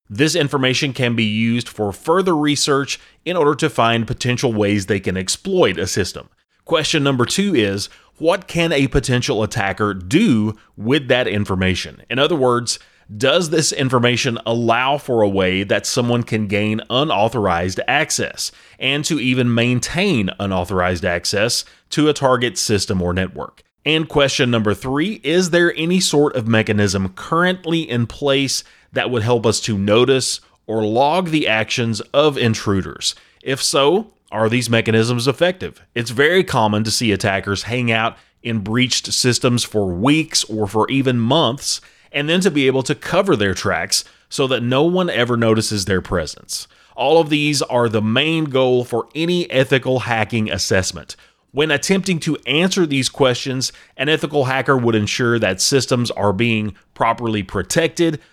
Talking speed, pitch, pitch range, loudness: 160 wpm, 120 Hz, 110-145 Hz, -17 LUFS